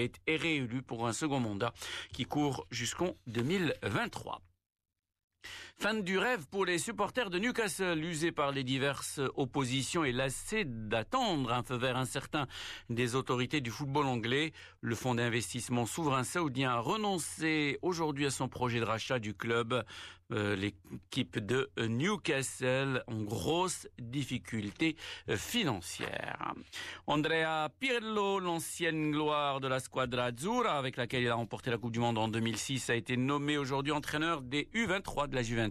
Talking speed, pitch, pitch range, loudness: 145 wpm, 135 Hz, 120-160 Hz, -34 LUFS